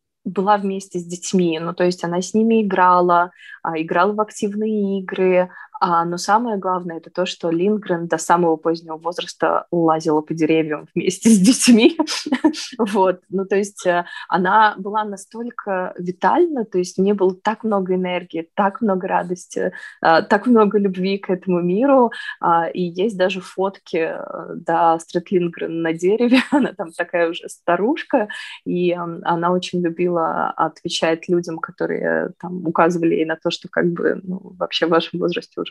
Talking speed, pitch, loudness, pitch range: 155 wpm, 180 Hz, -19 LUFS, 170-205 Hz